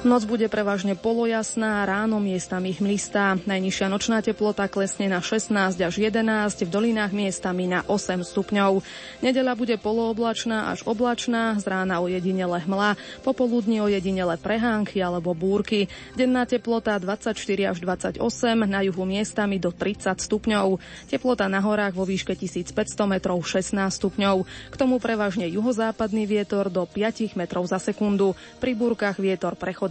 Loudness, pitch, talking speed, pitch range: -24 LUFS, 205 Hz, 140 wpm, 190-225 Hz